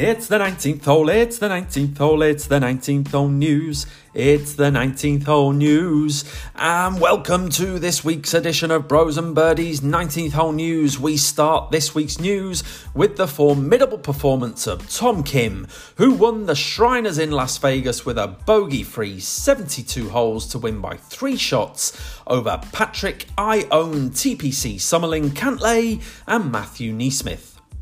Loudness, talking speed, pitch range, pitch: -19 LUFS, 150 wpm, 140-180 Hz, 155 Hz